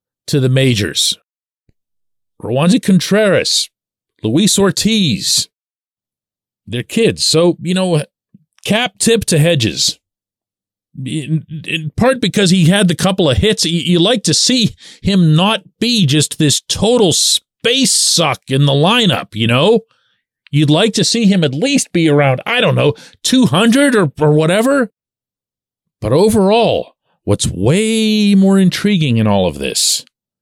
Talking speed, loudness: 135 wpm, -13 LUFS